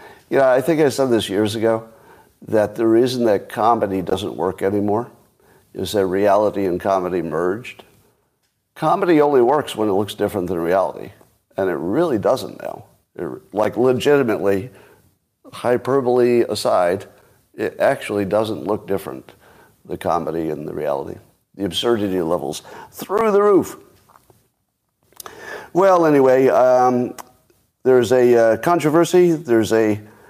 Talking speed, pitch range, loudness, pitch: 130 wpm, 100-130 Hz, -18 LUFS, 115 Hz